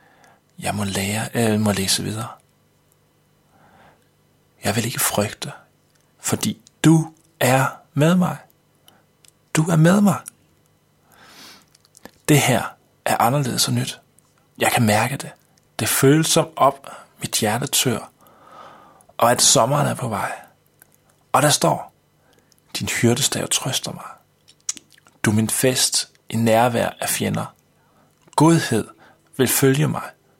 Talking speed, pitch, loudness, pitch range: 120 wpm, 135 Hz, -19 LUFS, 115-160 Hz